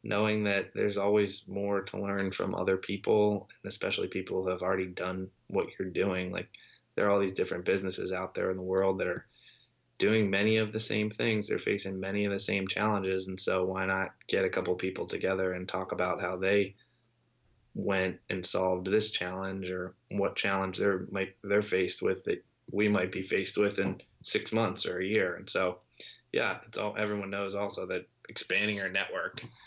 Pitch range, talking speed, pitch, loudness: 95-105 Hz, 200 wpm, 95 Hz, -31 LUFS